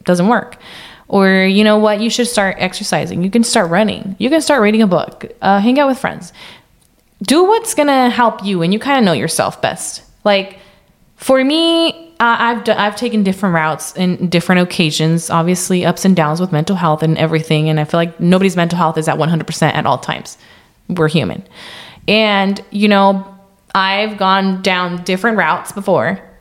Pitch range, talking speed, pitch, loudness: 170-215 Hz, 190 wpm, 195 Hz, -14 LUFS